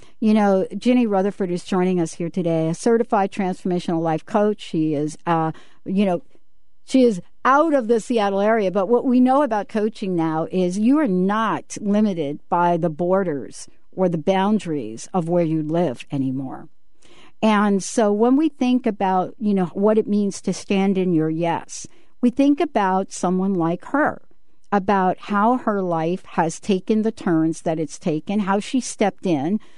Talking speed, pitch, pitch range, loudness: 175 wpm, 195 Hz, 170-215 Hz, -20 LUFS